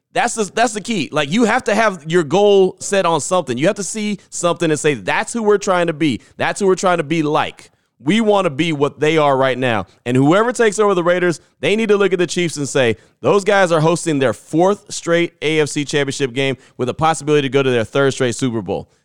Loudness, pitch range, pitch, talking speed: -16 LUFS, 145-200 Hz, 165 Hz, 250 wpm